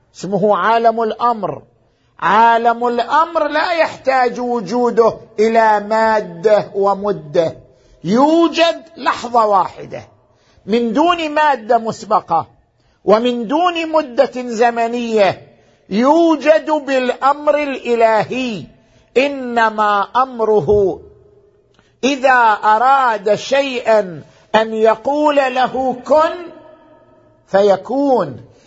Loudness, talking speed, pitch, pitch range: -15 LUFS, 75 wpm, 235 Hz, 210-285 Hz